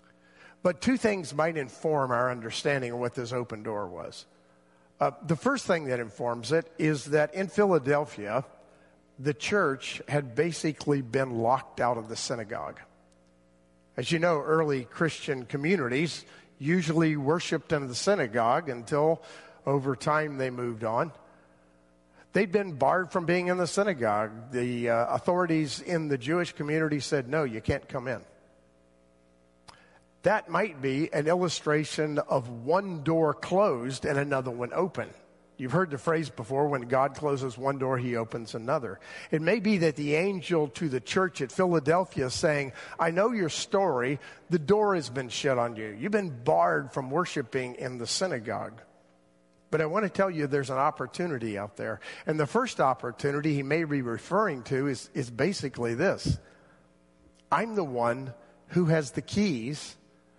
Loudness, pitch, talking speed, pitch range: -29 LUFS, 140 Hz, 160 wpm, 120-165 Hz